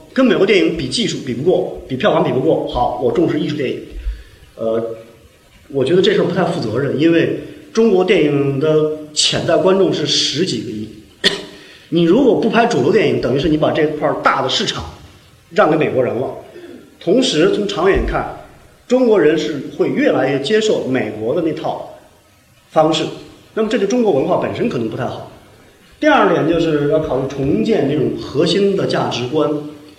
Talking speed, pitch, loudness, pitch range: 270 characters per minute, 155 Hz, -16 LUFS, 130-185 Hz